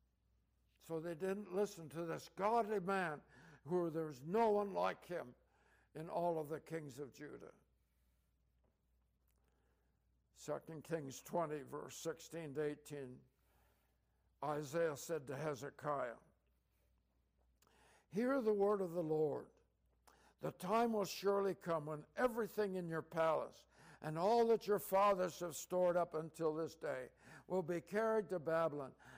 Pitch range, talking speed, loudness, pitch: 140-185 Hz, 130 wpm, -41 LUFS, 160 Hz